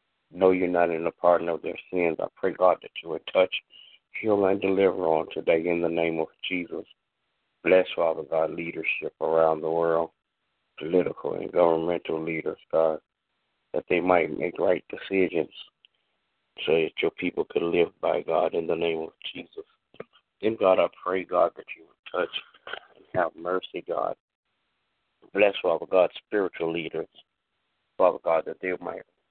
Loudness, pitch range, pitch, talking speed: -26 LUFS, 85-95 Hz, 85 Hz, 165 wpm